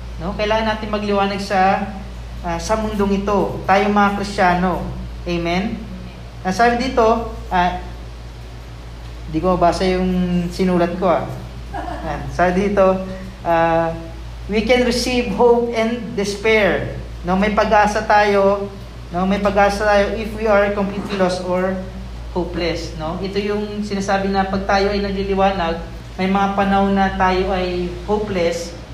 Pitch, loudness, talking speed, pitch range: 195 Hz, -18 LUFS, 140 wpm, 170-205 Hz